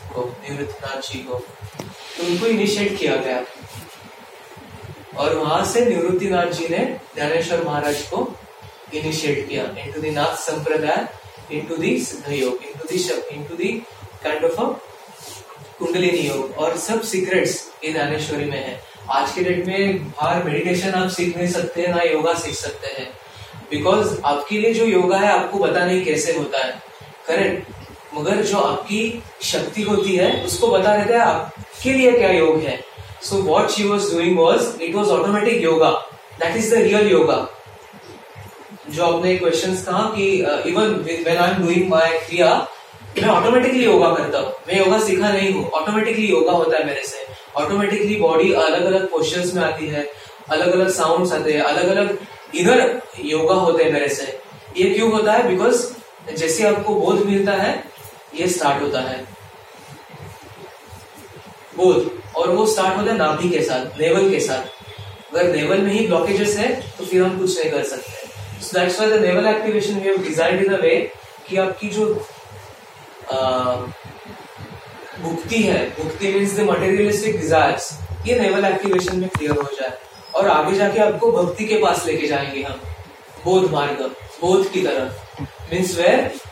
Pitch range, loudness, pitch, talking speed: 150-205 Hz, -19 LUFS, 175 Hz, 135 wpm